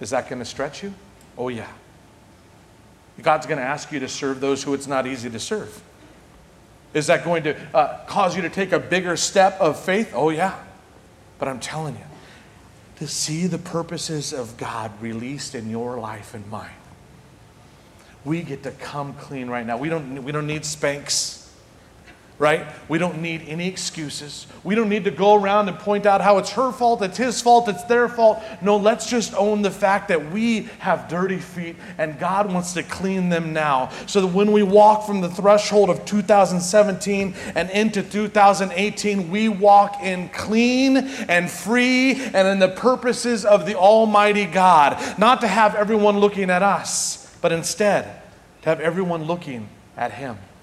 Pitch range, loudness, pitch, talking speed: 145-205 Hz, -20 LUFS, 180 Hz, 180 wpm